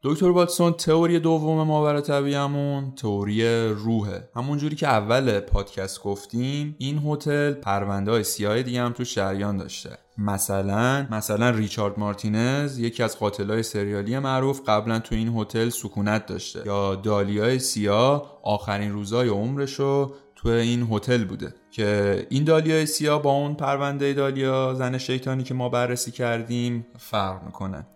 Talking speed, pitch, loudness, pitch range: 140 wpm, 120 Hz, -24 LUFS, 105-140 Hz